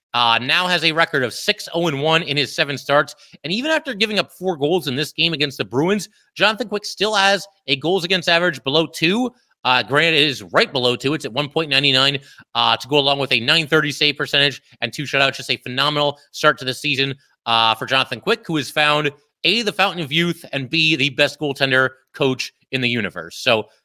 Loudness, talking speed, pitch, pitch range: -18 LUFS, 215 wpm, 145 Hz, 135-170 Hz